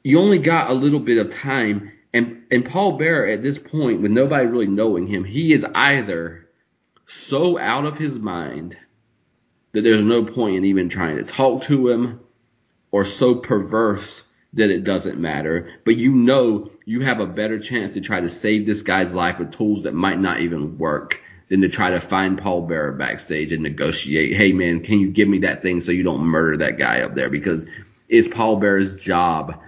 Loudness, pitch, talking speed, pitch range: -19 LUFS, 105 Hz, 200 wpm, 90-120 Hz